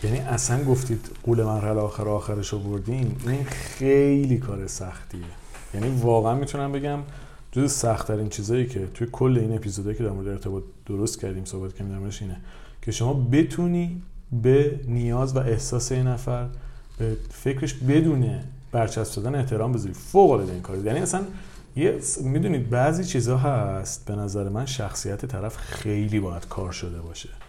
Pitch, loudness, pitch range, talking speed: 120 Hz, -25 LUFS, 105-130 Hz, 155 wpm